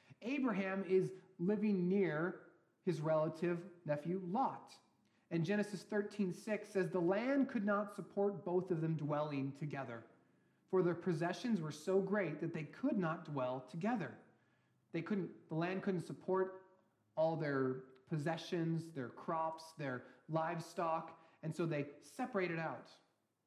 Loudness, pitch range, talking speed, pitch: -40 LUFS, 160-190 Hz, 135 wpm, 175 Hz